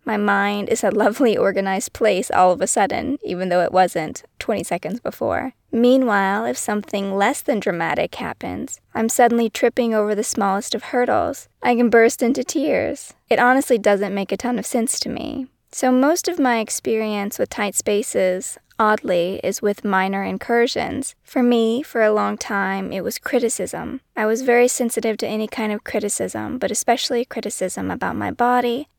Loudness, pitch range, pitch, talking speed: -20 LUFS, 200-245 Hz, 225 Hz, 175 wpm